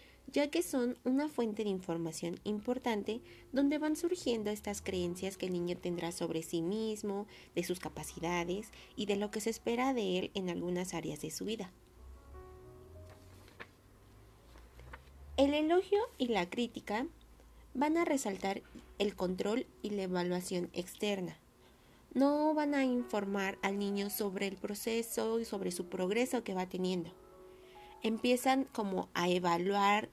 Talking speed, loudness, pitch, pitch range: 140 wpm, -36 LUFS, 200 Hz, 175-240 Hz